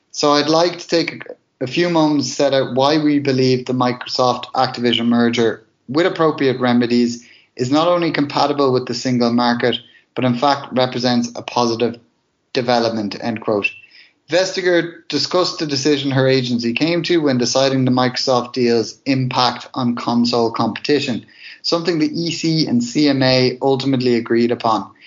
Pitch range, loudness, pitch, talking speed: 120-150 Hz, -17 LUFS, 130 Hz, 150 wpm